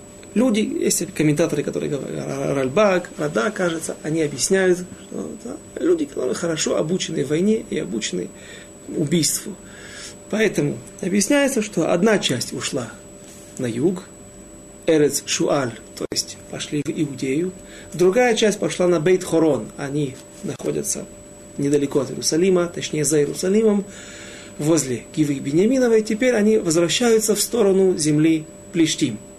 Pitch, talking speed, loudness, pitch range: 175 Hz, 120 wpm, -20 LUFS, 150-210 Hz